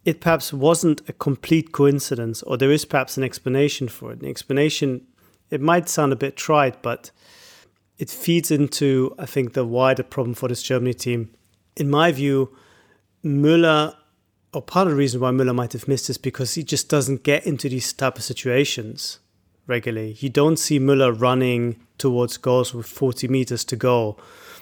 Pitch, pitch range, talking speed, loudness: 135 Hz, 125-145 Hz, 180 wpm, -21 LUFS